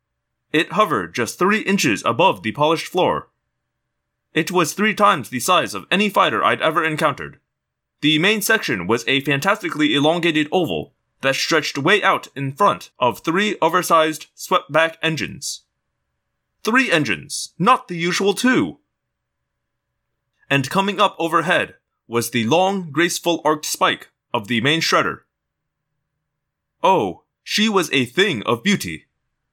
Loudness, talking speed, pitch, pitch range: -18 LUFS, 140 wpm, 165 Hz, 140-195 Hz